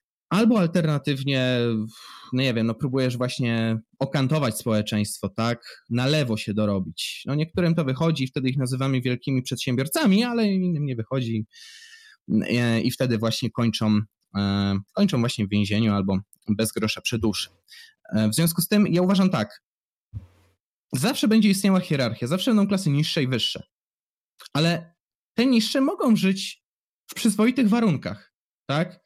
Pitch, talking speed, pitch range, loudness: 135 Hz, 145 wpm, 115-185 Hz, -23 LUFS